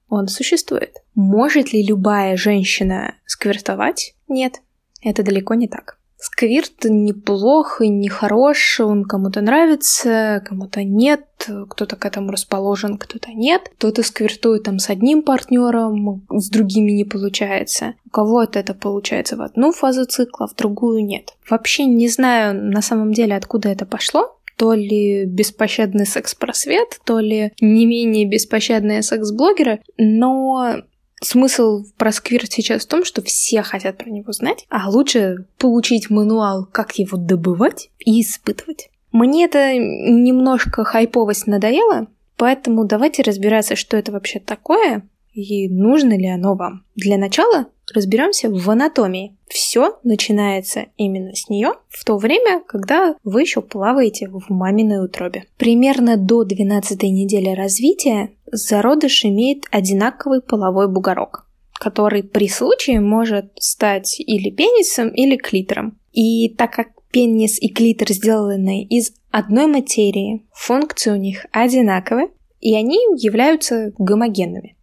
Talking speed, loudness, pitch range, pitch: 130 wpm, -16 LUFS, 205-250 Hz, 220 Hz